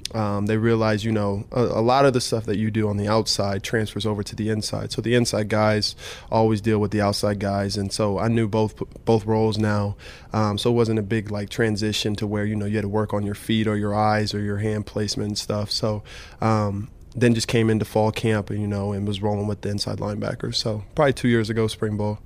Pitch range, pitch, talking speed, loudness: 105-110 Hz, 105 Hz, 250 wpm, -23 LUFS